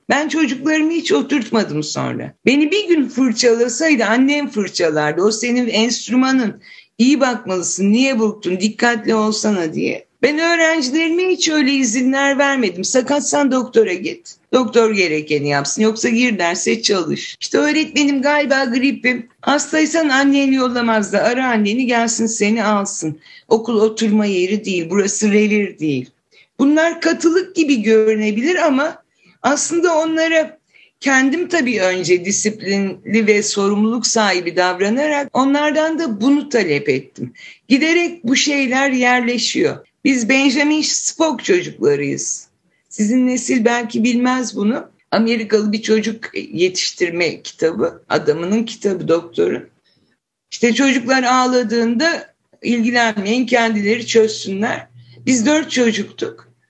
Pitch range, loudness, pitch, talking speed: 215-285 Hz, -16 LUFS, 240 Hz, 115 wpm